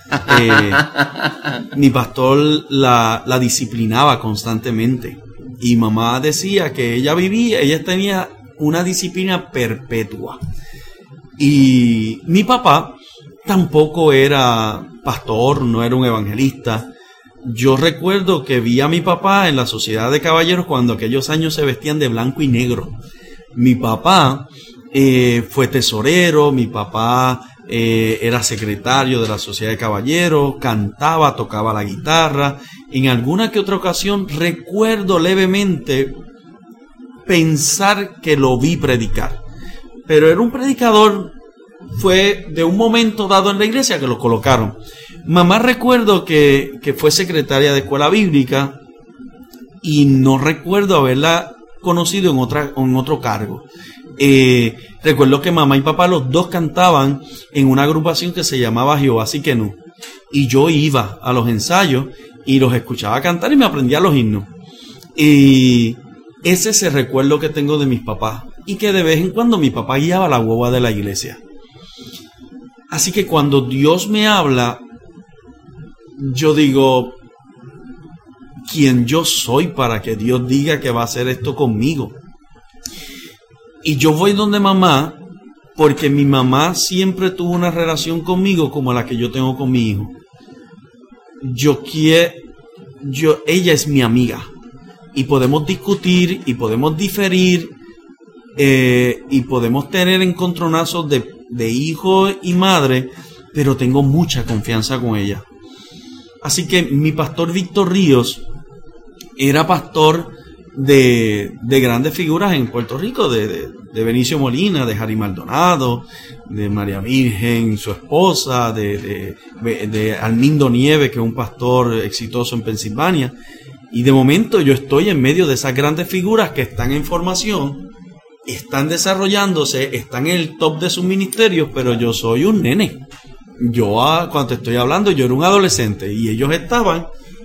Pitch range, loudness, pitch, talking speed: 120-170 Hz, -15 LUFS, 140 Hz, 140 wpm